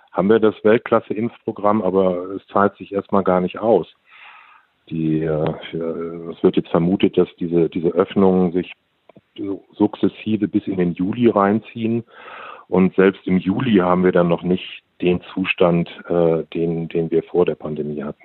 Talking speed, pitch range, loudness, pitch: 150 wpm, 85-100 Hz, -19 LUFS, 90 Hz